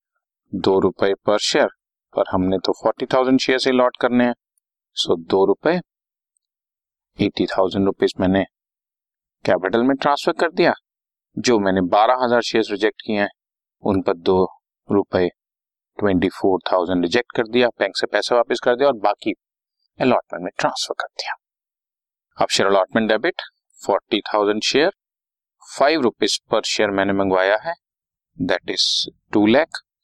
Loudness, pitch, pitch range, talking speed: -19 LUFS, 110 Hz, 95-125 Hz, 150 wpm